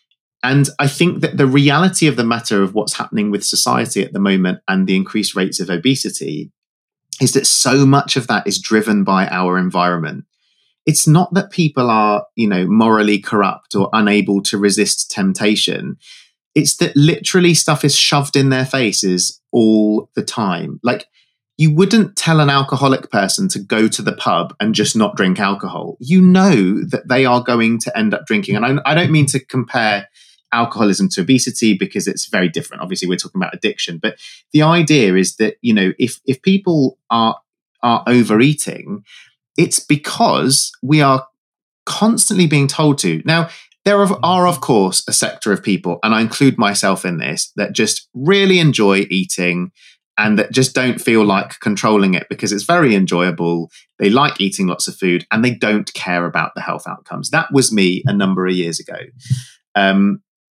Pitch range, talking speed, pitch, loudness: 100-155 Hz, 180 wpm, 125 Hz, -15 LUFS